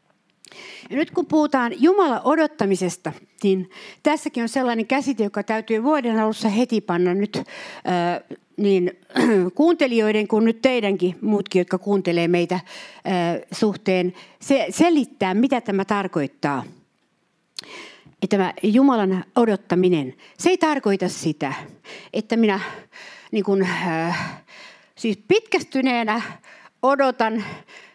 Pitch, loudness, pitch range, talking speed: 215 Hz, -21 LUFS, 185-260 Hz, 110 wpm